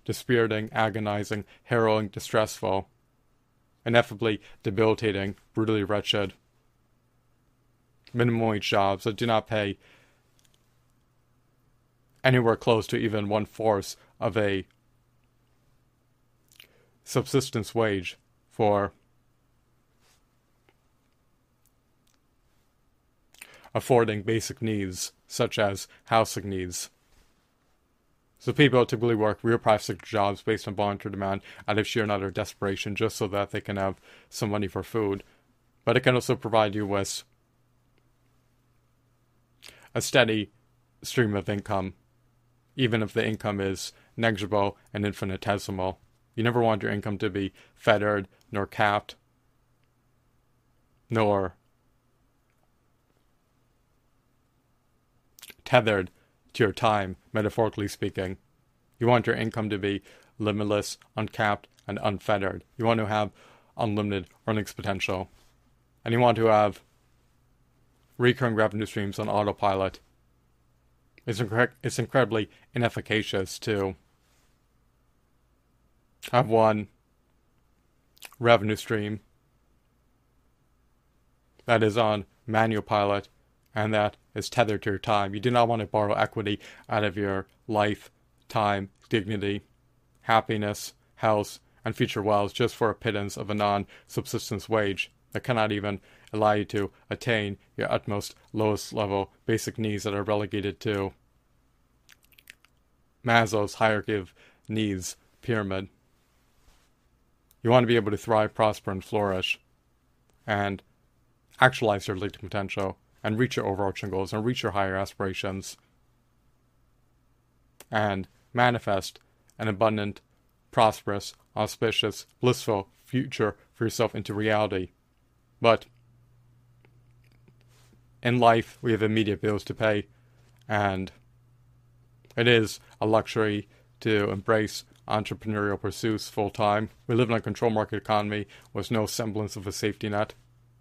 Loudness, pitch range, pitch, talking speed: -27 LUFS, 100-120 Hz, 110 Hz, 110 wpm